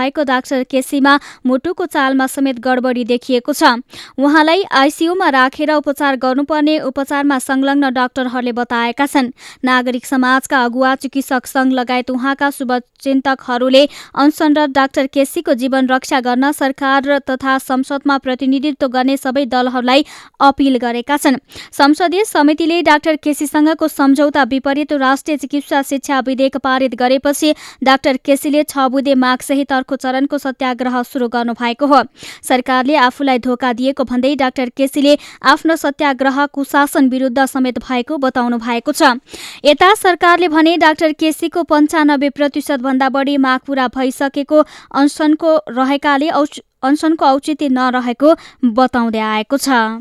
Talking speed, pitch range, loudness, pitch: 125 wpm, 260-290 Hz, -14 LUFS, 275 Hz